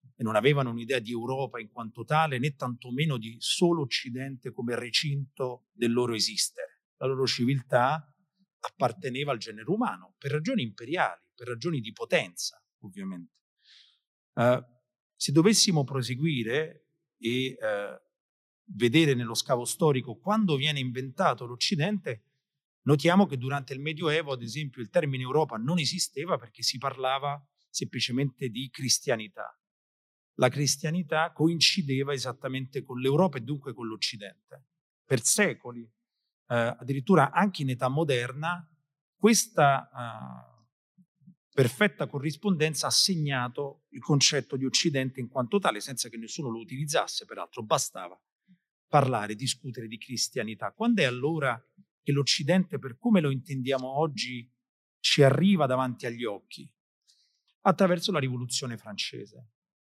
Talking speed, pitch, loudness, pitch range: 125 wpm, 135 Hz, -28 LUFS, 125-160 Hz